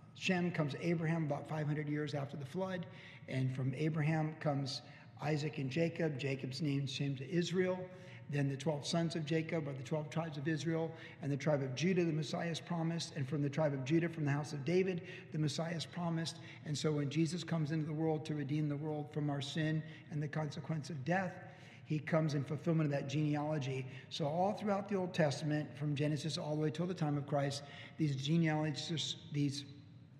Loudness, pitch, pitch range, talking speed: -38 LUFS, 155 Hz, 145-165 Hz, 200 wpm